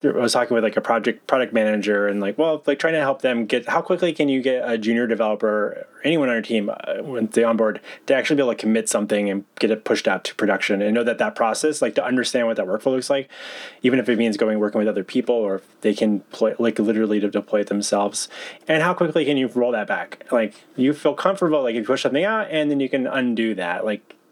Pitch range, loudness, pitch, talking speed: 105-140 Hz, -21 LUFS, 115 Hz, 265 wpm